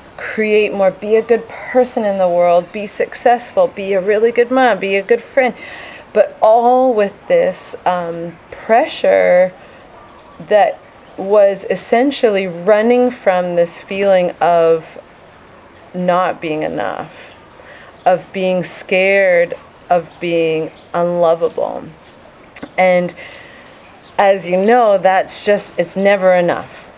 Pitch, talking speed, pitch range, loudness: 195 Hz, 115 wpm, 175-235 Hz, -14 LUFS